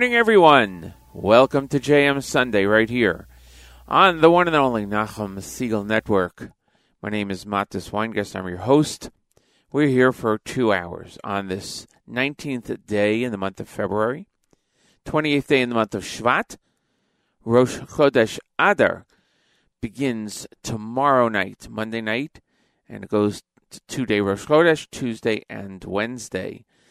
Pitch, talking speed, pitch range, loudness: 110 Hz, 145 wpm, 100-135 Hz, -21 LUFS